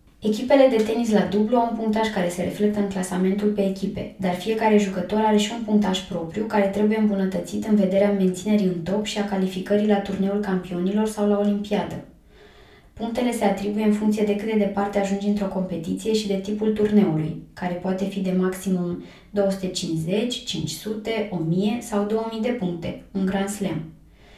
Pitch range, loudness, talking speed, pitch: 185-215 Hz, -23 LUFS, 175 wpm, 205 Hz